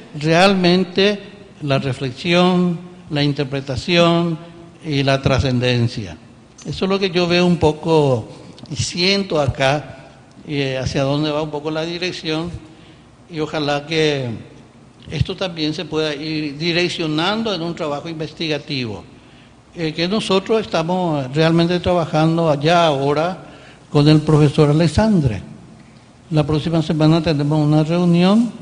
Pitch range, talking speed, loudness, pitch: 145-175 Hz, 120 wpm, -18 LUFS, 155 Hz